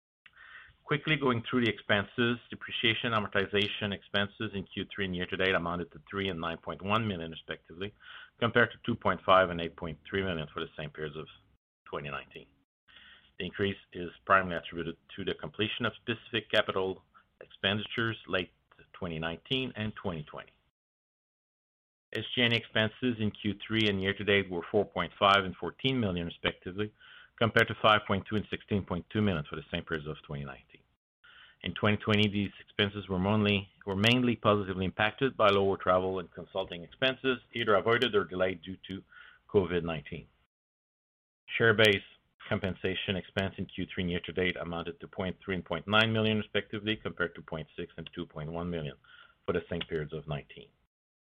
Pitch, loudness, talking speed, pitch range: 100 Hz, -31 LUFS, 145 wpm, 85-110 Hz